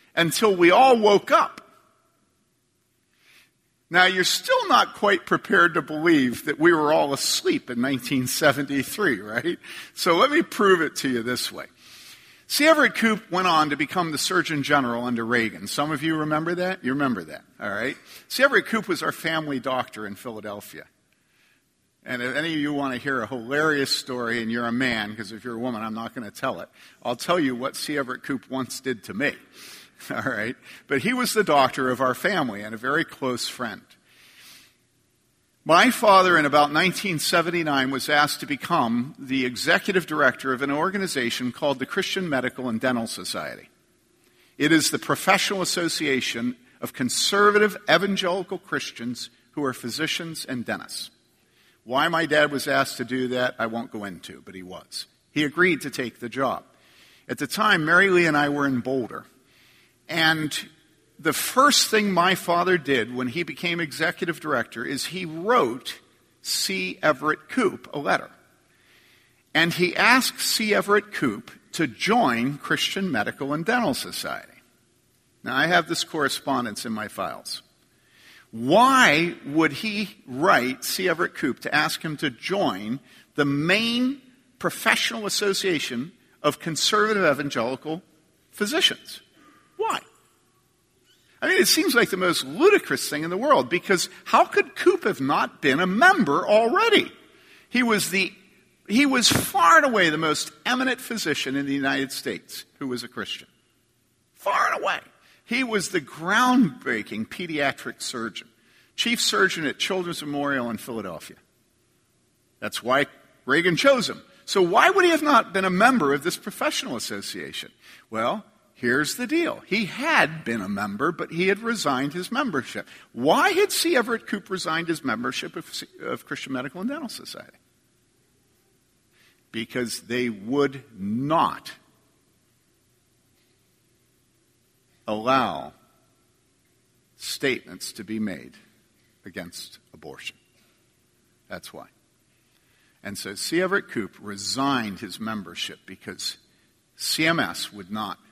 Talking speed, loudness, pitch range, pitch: 150 wpm, -23 LUFS, 125-205 Hz, 155 Hz